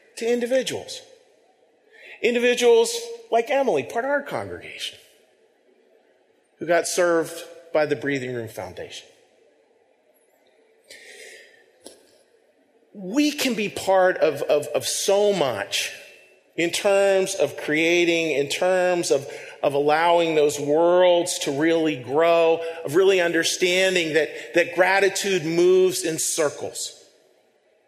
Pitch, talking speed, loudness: 185 Hz, 105 wpm, -21 LUFS